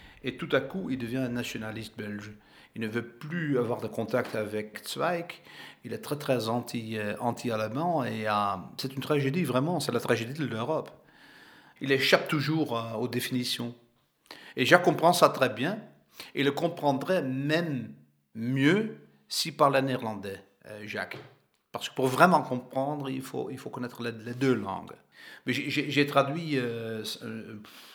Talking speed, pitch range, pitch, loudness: 170 wpm, 110-145 Hz, 125 Hz, -29 LUFS